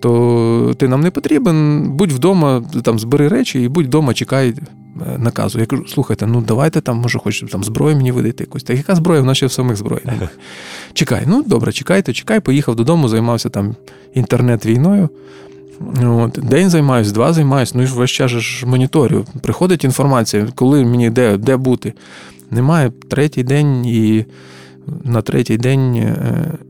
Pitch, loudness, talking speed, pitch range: 125 Hz, -14 LUFS, 155 wpm, 115-140 Hz